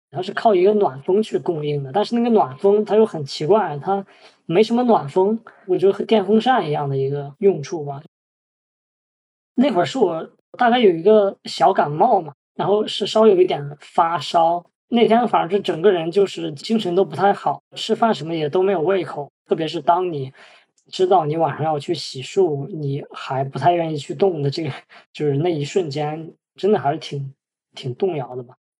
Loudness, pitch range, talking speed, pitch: -19 LUFS, 145-205 Hz, 280 characters per minute, 180 Hz